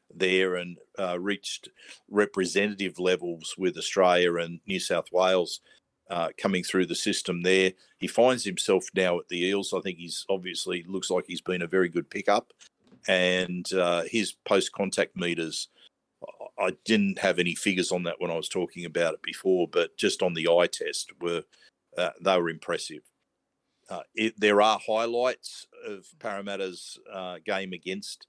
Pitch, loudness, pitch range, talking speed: 95 Hz, -27 LUFS, 90-110 Hz, 165 wpm